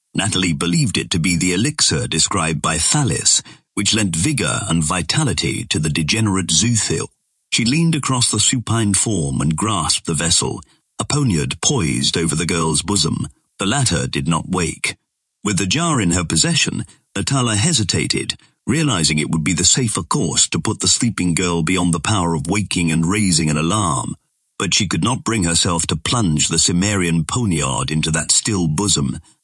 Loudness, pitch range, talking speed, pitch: -17 LUFS, 80-110 Hz, 175 wpm, 90 Hz